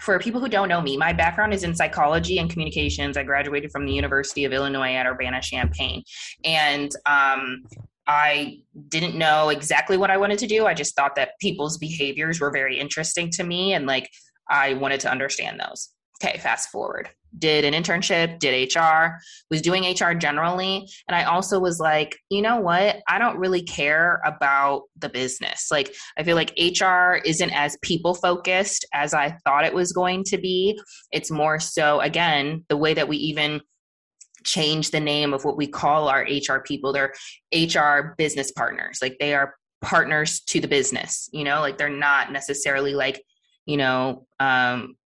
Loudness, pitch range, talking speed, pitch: -22 LUFS, 140-175 Hz, 180 wpm, 150 Hz